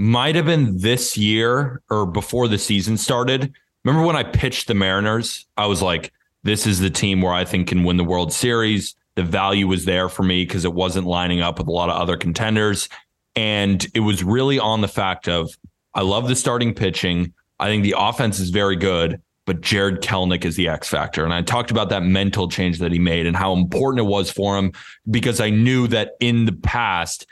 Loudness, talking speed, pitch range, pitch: -19 LUFS, 215 wpm, 90-115 Hz, 100 Hz